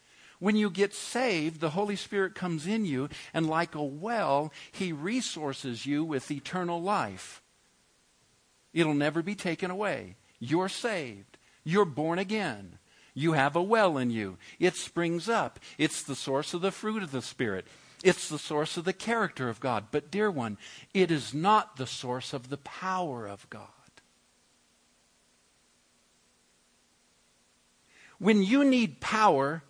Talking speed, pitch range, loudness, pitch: 150 wpm, 135-195 Hz, -30 LUFS, 165 Hz